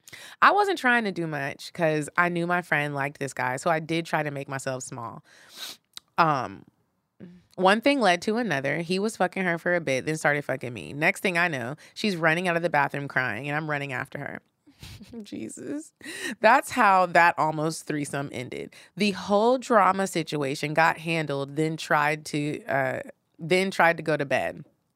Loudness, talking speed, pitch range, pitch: -25 LUFS, 190 wpm, 145-190 Hz, 165 Hz